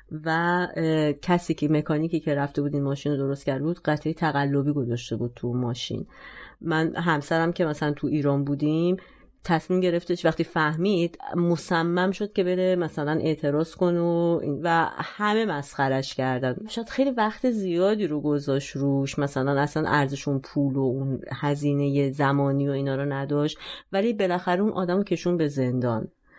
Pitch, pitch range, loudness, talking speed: 155 Hz, 140-175 Hz, -25 LUFS, 155 wpm